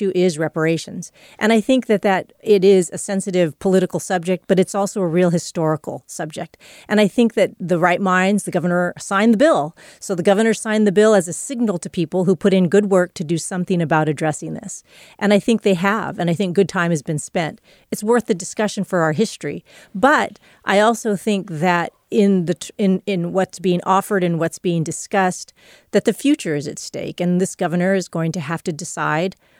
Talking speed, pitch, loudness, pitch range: 215 wpm, 185 Hz, -18 LUFS, 175-205 Hz